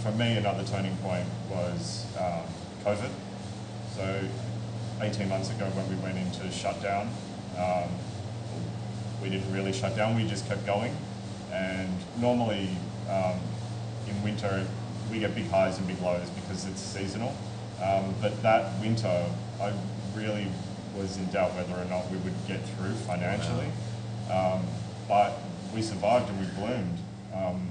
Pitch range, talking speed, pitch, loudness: 95-110 Hz, 145 wpm, 100 Hz, -31 LUFS